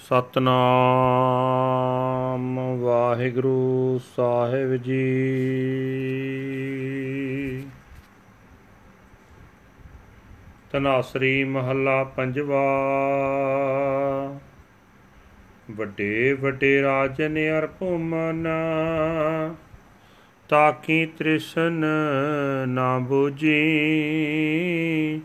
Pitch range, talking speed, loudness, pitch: 130-150 Hz, 50 wpm, -23 LUFS, 135 Hz